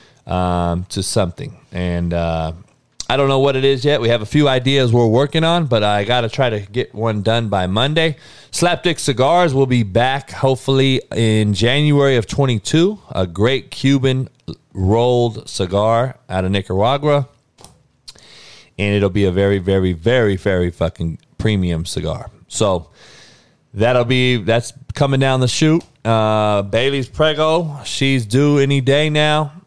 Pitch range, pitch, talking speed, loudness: 100-140 Hz, 120 Hz, 150 wpm, -16 LUFS